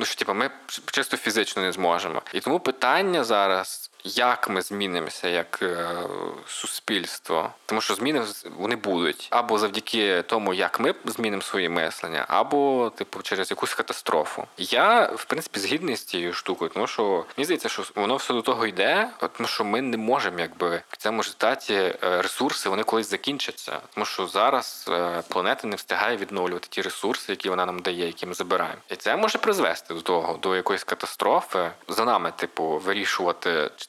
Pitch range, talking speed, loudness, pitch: 90-125 Hz, 175 wpm, -25 LUFS, 95 Hz